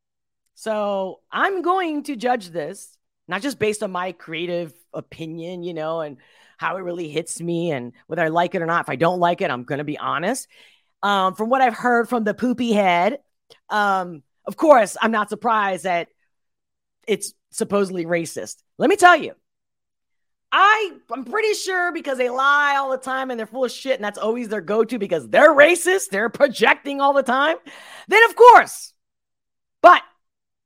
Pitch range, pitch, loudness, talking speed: 175-280 Hz, 220 Hz, -19 LUFS, 185 wpm